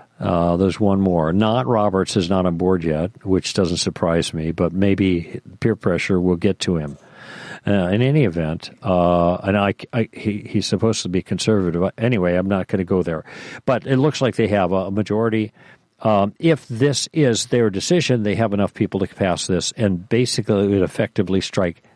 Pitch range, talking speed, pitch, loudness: 90-115 Hz, 195 wpm, 100 Hz, -19 LUFS